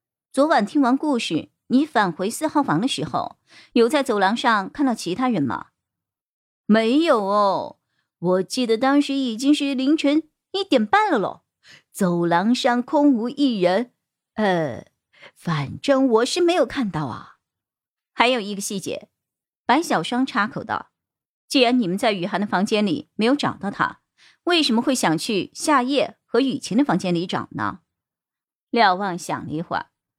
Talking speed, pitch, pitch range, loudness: 225 characters per minute, 235 Hz, 190-275 Hz, -21 LUFS